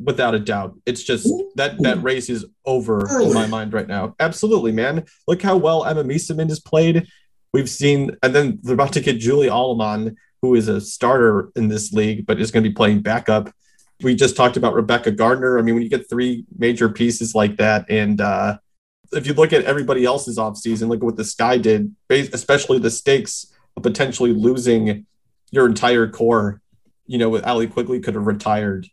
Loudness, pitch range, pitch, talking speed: -18 LUFS, 110-135 Hz, 120 Hz, 200 wpm